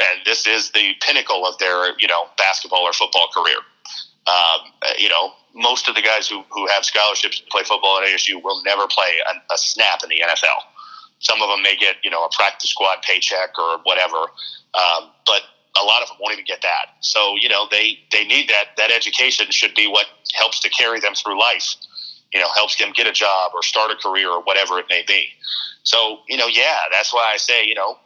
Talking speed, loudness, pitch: 225 wpm, -16 LUFS, 105 Hz